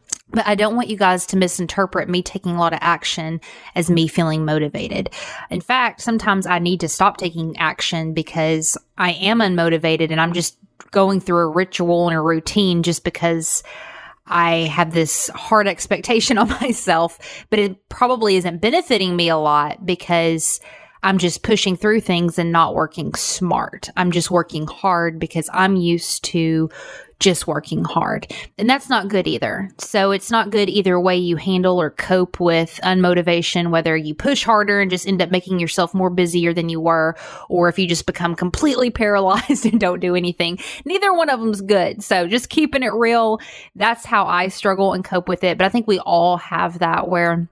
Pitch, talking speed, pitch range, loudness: 180 Hz, 185 wpm, 170-205 Hz, -18 LUFS